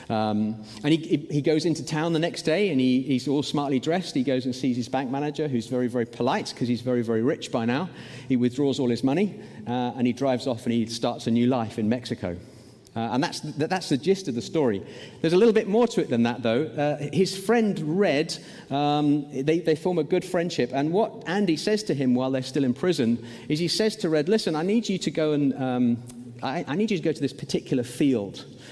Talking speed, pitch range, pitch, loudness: 245 wpm, 125-165 Hz, 140 Hz, -25 LUFS